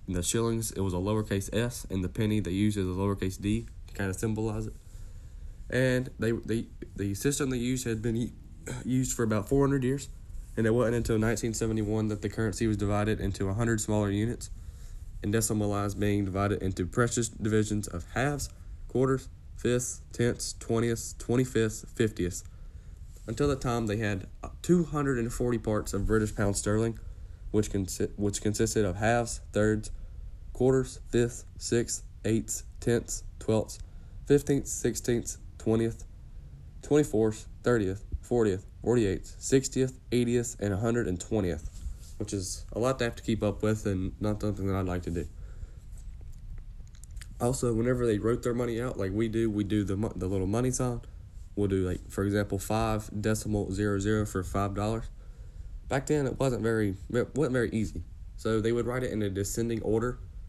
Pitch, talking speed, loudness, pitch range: 105 Hz, 170 wpm, -30 LUFS, 95-115 Hz